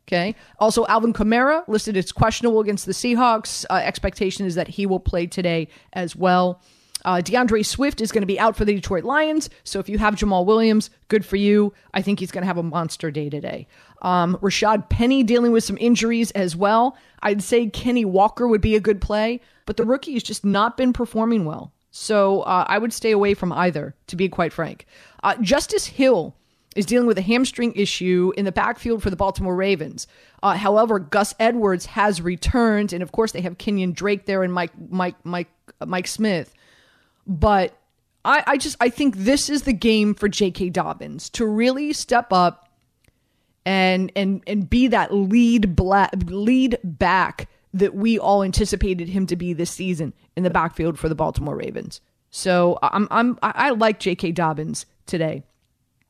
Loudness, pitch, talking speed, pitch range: -20 LUFS, 200 Hz, 190 wpm, 185-225 Hz